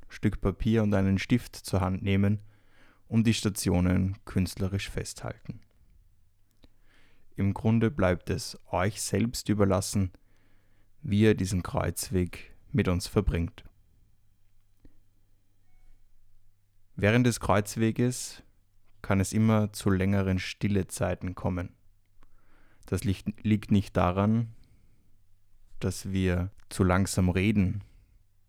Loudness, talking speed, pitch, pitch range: -28 LUFS, 100 wpm, 100 Hz, 95-105 Hz